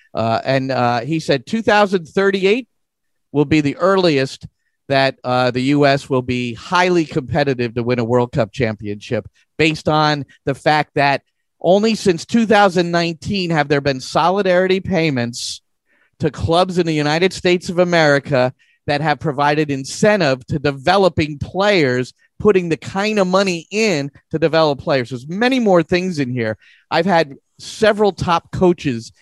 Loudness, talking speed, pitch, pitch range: -17 LUFS, 150 wpm, 155 Hz, 135-180 Hz